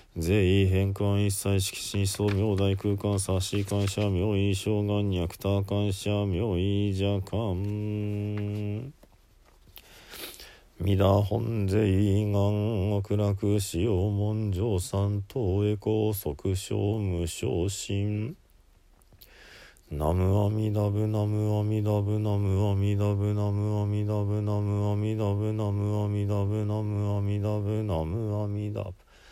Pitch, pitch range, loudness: 105 Hz, 100-105 Hz, -28 LUFS